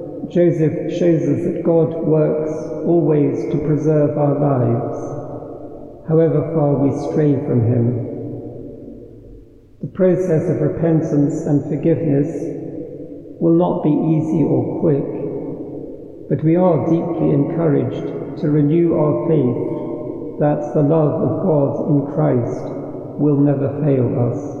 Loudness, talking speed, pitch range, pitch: -17 LUFS, 120 wpm, 145-160 Hz, 150 Hz